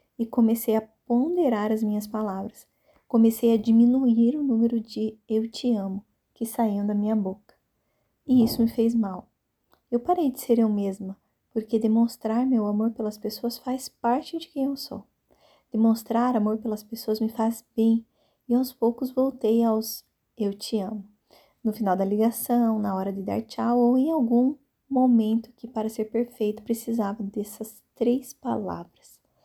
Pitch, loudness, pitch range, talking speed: 230 Hz, -25 LUFS, 220-240 Hz, 165 wpm